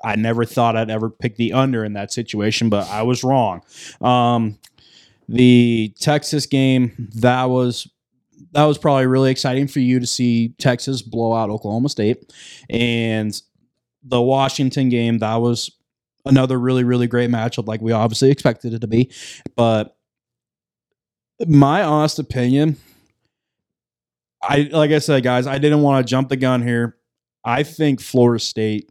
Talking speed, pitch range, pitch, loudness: 155 wpm, 115-135 Hz, 125 Hz, -18 LUFS